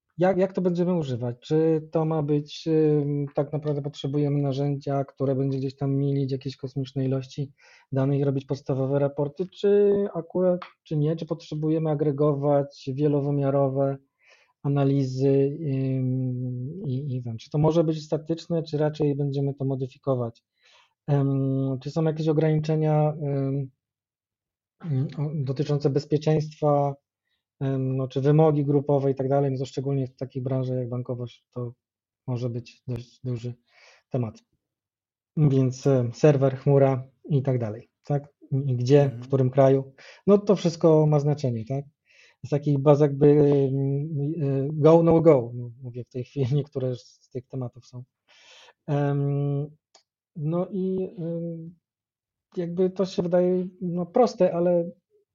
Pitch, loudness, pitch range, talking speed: 140 Hz, -25 LUFS, 135-155 Hz, 125 wpm